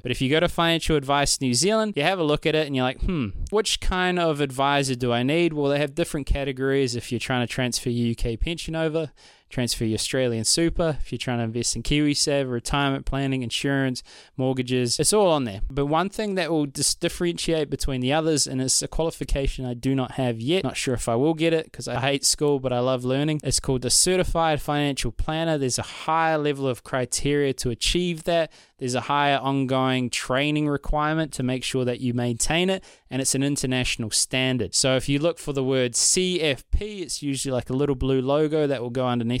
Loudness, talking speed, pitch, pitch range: -23 LUFS, 220 wpm, 135 Hz, 125-155 Hz